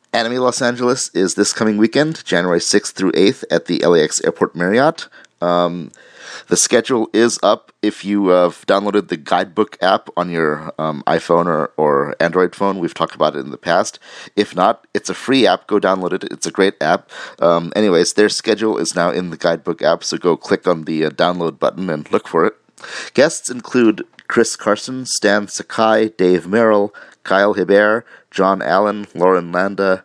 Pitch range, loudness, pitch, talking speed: 90-110 Hz, -16 LUFS, 100 Hz, 180 wpm